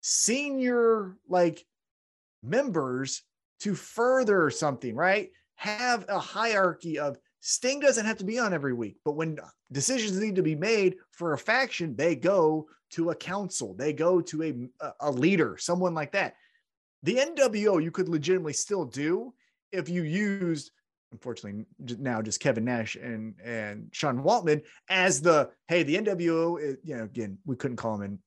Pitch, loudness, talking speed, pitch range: 170 Hz, -28 LUFS, 160 wpm, 135-205 Hz